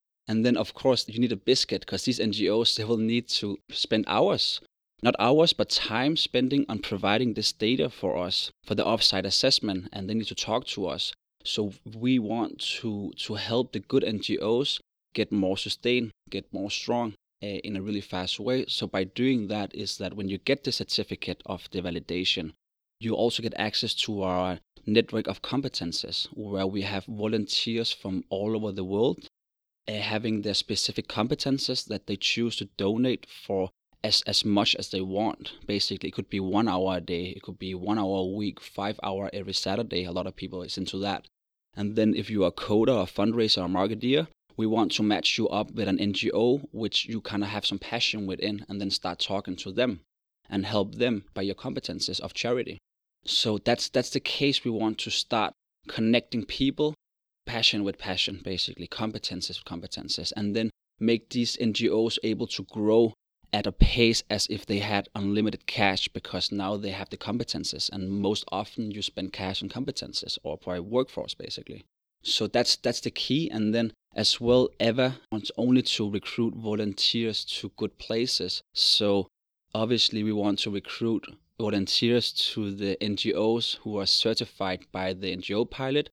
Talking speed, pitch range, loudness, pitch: 185 wpm, 100-115 Hz, -27 LUFS, 105 Hz